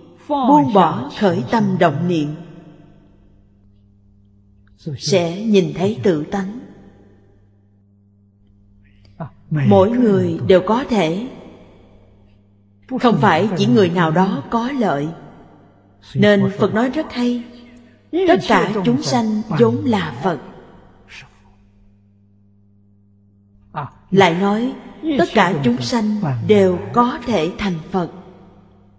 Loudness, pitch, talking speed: -17 LUFS, 165 Hz, 95 wpm